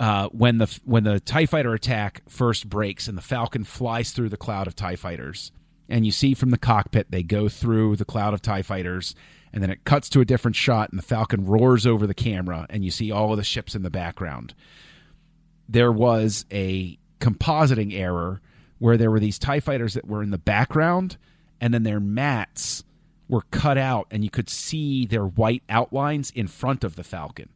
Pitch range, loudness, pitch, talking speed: 100-125 Hz, -23 LUFS, 110 Hz, 205 wpm